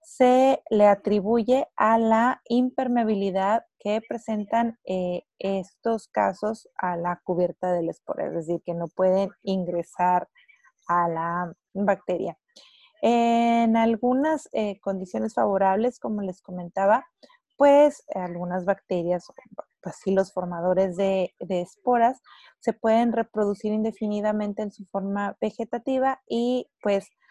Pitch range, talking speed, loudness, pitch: 185-235 Hz, 115 wpm, -25 LUFS, 205 Hz